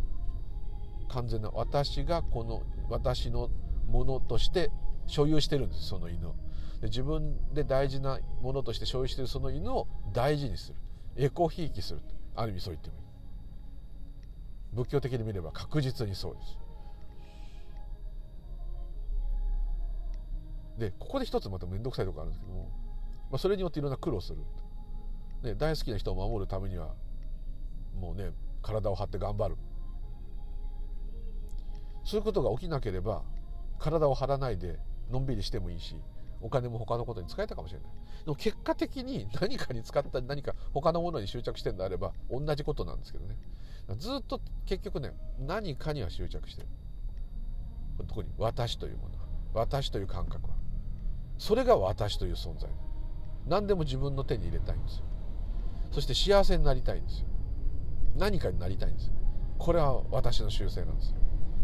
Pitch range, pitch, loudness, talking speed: 90-135 Hz, 105 Hz, -34 LUFS, 325 characters per minute